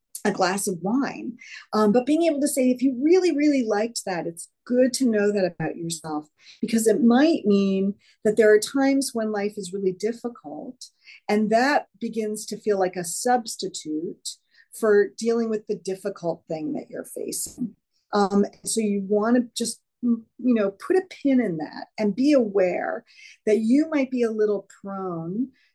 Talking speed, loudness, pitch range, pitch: 175 wpm, -23 LUFS, 200-250 Hz, 215 Hz